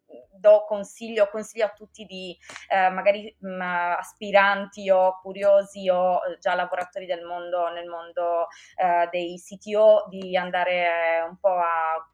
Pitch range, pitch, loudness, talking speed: 175-200 Hz, 185 Hz, -23 LUFS, 135 wpm